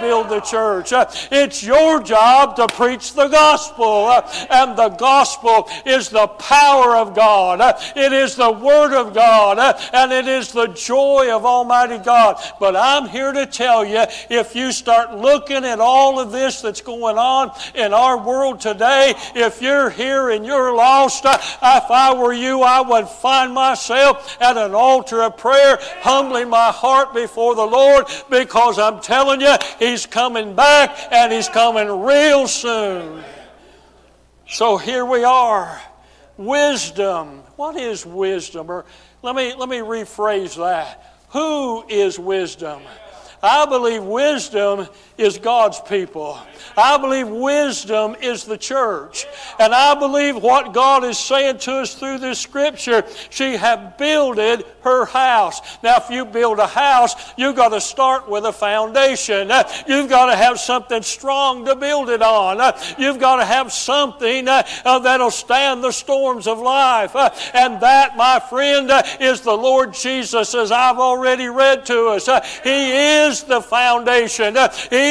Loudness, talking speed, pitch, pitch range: -15 LUFS, 155 wpm, 250 Hz, 225-270 Hz